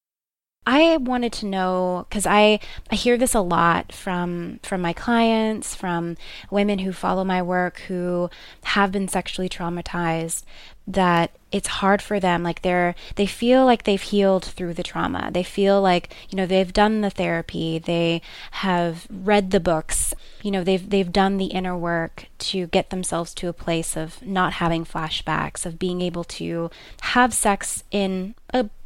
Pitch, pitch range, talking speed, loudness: 185 Hz, 175-205 Hz, 170 wpm, -22 LUFS